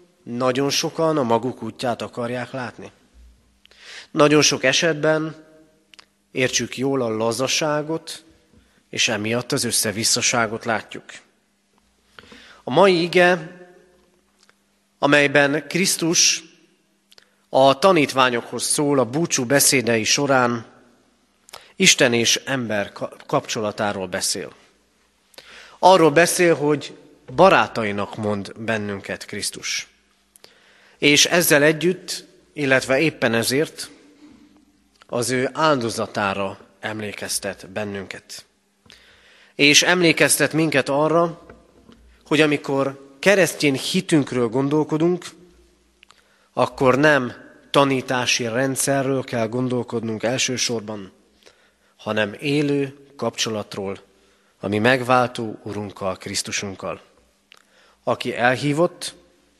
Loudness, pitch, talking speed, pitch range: -19 LUFS, 135 Hz, 80 wpm, 115-155 Hz